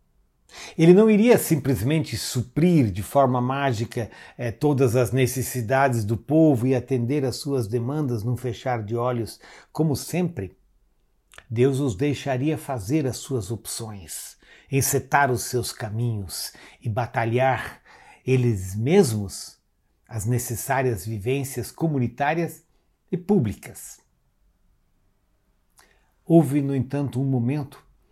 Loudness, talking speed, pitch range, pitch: -23 LUFS, 110 wpm, 115-140 Hz, 130 Hz